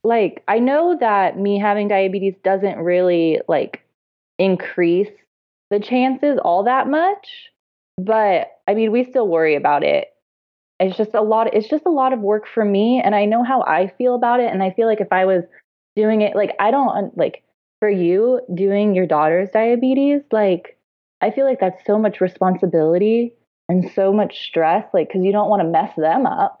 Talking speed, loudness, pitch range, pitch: 190 wpm, -18 LUFS, 185-240 Hz, 205 Hz